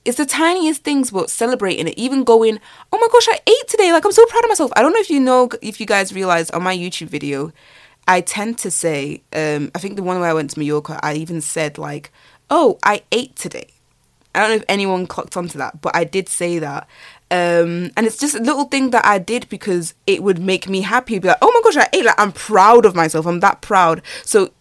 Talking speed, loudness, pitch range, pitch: 250 wpm, -16 LUFS, 170-250 Hz, 195 Hz